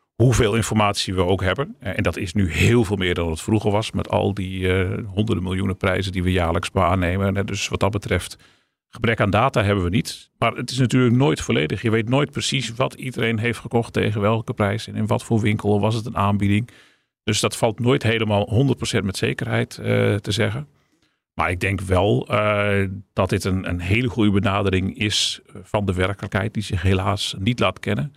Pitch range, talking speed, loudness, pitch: 95-115 Hz, 205 wpm, -21 LUFS, 105 Hz